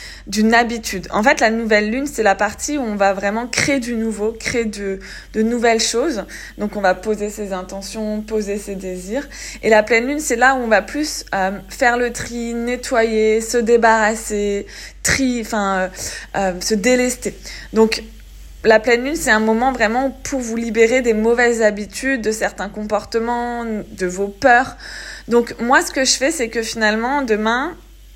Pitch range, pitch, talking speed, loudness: 210-240 Hz, 225 Hz, 180 wpm, -18 LUFS